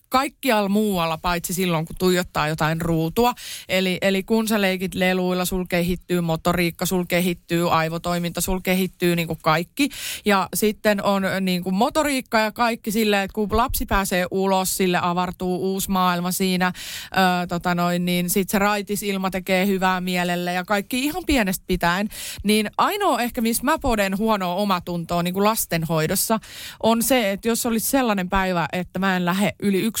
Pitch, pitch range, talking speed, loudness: 185 Hz, 180-215 Hz, 160 wpm, -21 LUFS